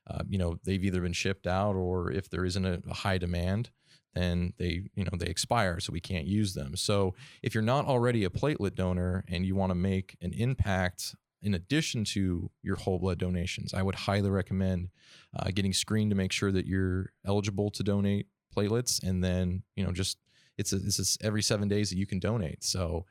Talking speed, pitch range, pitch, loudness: 215 wpm, 90-105 Hz, 95 Hz, -31 LUFS